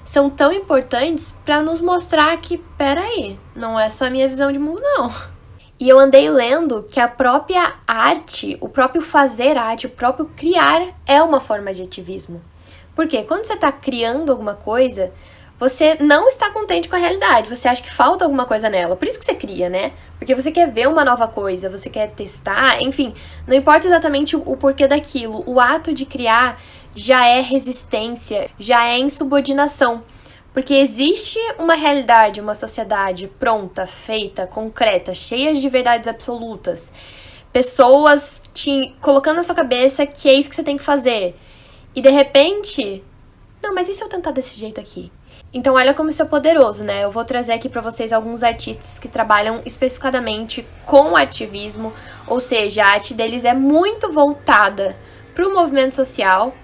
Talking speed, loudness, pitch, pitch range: 175 wpm, -16 LUFS, 265 Hz, 230-295 Hz